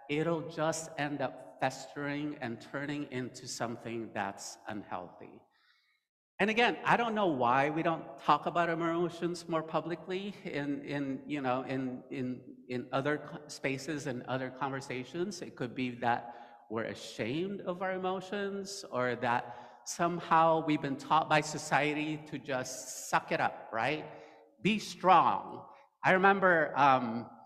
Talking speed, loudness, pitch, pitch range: 140 wpm, -33 LUFS, 145 Hz, 125-170 Hz